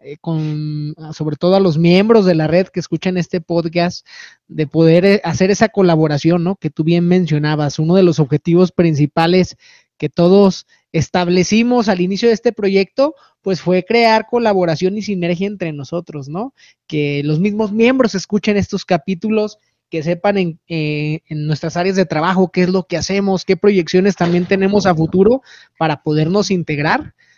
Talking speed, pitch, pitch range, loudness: 165 wpm, 180 Hz, 160-195 Hz, -15 LUFS